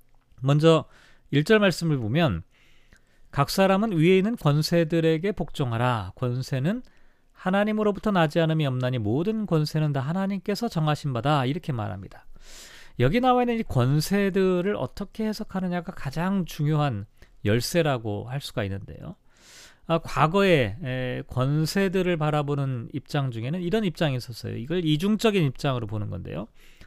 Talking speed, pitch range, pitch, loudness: 315 characters per minute, 130-190 Hz, 155 Hz, -25 LUFS